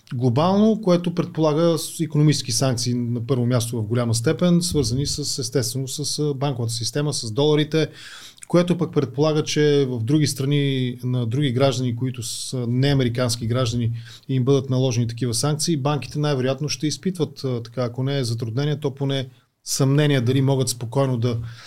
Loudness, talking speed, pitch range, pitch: -22 LUFS, 150 wpm, 125-150 Hz, 135 Hz